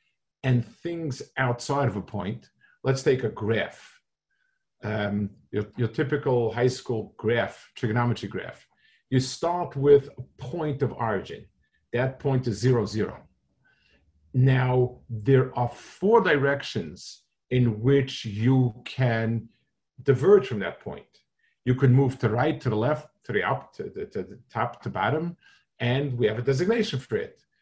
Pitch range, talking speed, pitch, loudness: 115-145 Hz, 150 wpm, 130 Hz, -26 LUFS